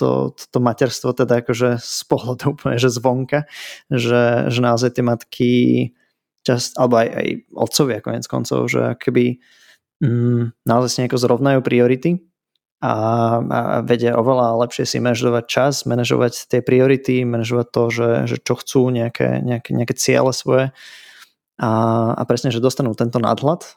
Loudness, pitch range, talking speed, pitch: -18 LUFS, 115-130 Hz, 140 wpm, 120 Hz